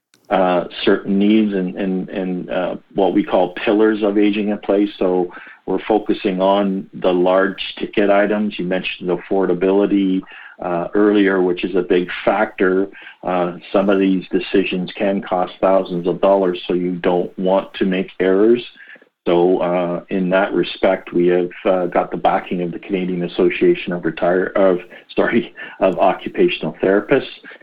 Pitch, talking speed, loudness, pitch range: 95 Hz, 160 wpm, -18 LUFS, 90-100 Hz